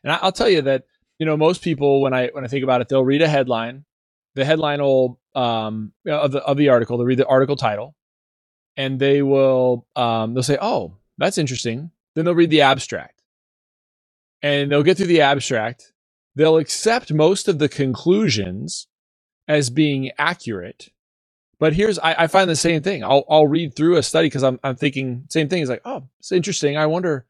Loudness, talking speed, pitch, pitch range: -19 LUFS, 205 wpm, 140 Hz, 130-160 Hz